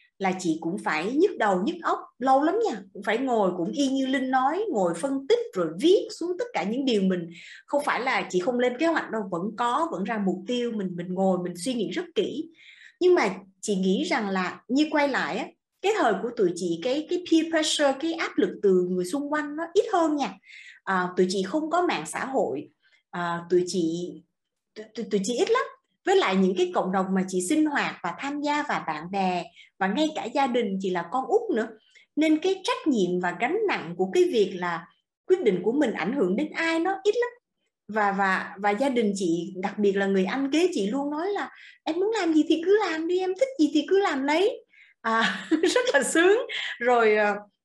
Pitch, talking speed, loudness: 260 Hz, 230 wpm, -25 LUFS